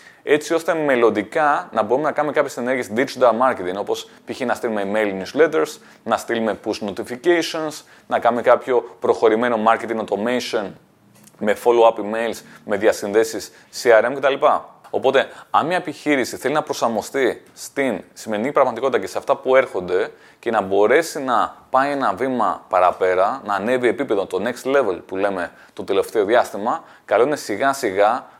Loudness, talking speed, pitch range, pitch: -20 LUFS, 150 wpm, 115-165 Hz, 130 Hz